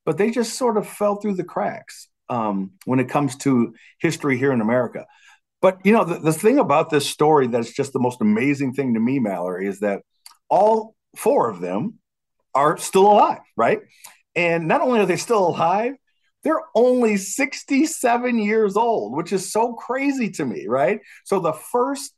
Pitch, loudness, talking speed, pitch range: 200 Hz, -20 LUFS, 185 wpm, 145-235 Hz